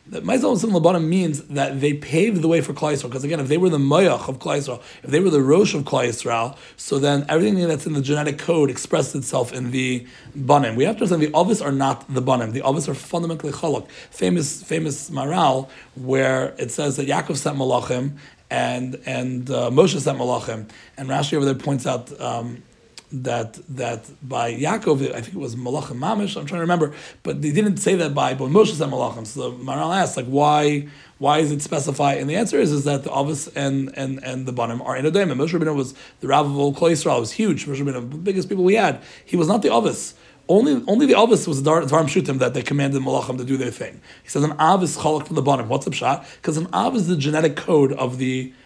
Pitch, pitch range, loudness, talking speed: 145 Hz, 130-165 Hz, -21 LUFS, 235 wpm